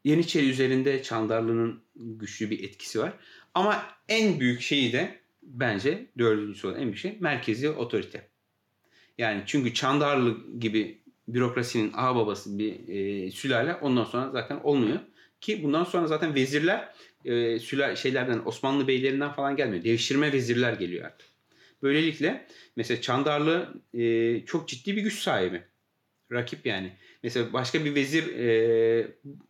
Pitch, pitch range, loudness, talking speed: 130 Hz, 115-150 Hz, -27 LUFS, 130 wpm